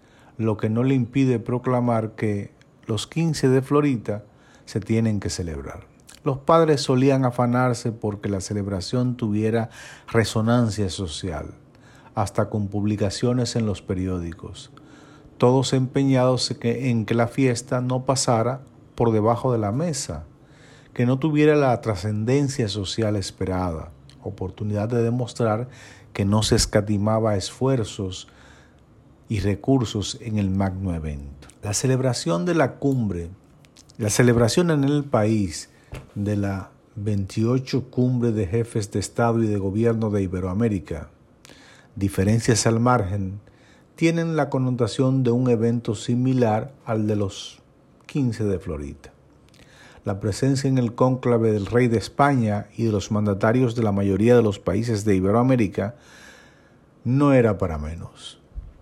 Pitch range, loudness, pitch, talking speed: 105-130 Hz, -22 LUFS, 115 Hz, 130 wpm